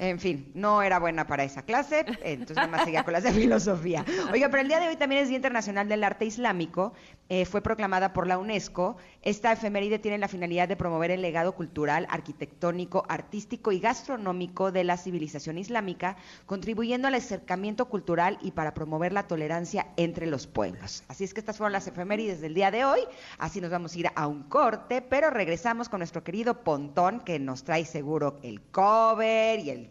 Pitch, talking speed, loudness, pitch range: 185 Hz, 200 wpm, -28 LUFS, 170-220 Hz